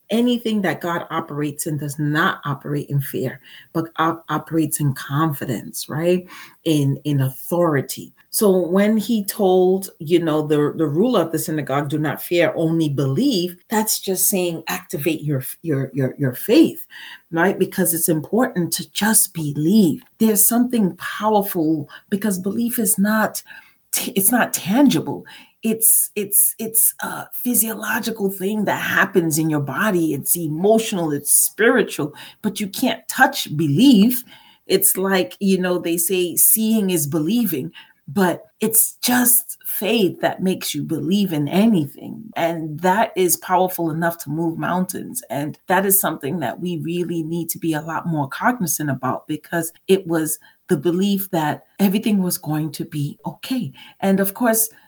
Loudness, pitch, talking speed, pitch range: -19 LUFS, 175 Hz, 155 wpm, 155-210 Hz